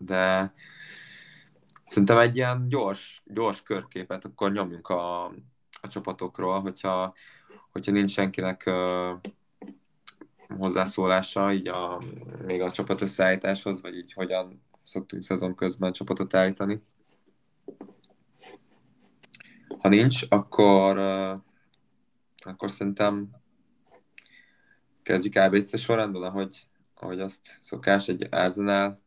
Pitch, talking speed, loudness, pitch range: 95 Hz, 90 wpm, -26 LUFS, 95-100 Hz